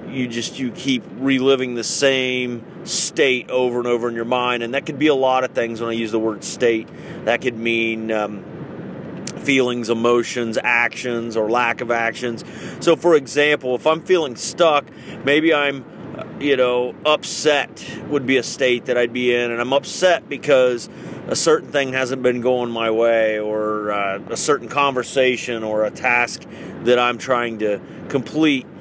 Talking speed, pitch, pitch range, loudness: 175 wpm, 125 Hz, 115-135 Hz, -19 LUFS